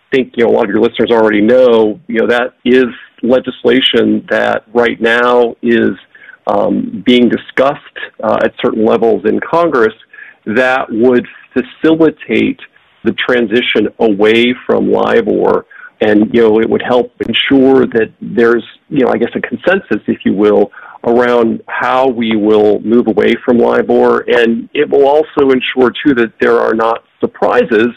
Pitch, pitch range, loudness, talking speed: 120 Hz, 110-125 Hz, -11 LUFS, 155 wpm